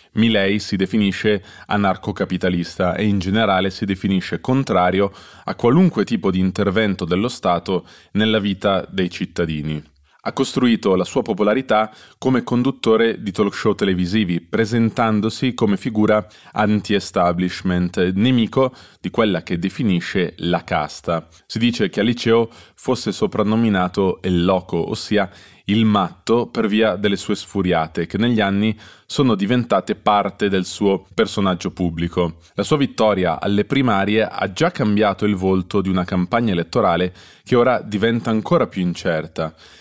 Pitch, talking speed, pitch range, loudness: 100 Hz, 135 wpm, 90-110 Hz, -19 LUFS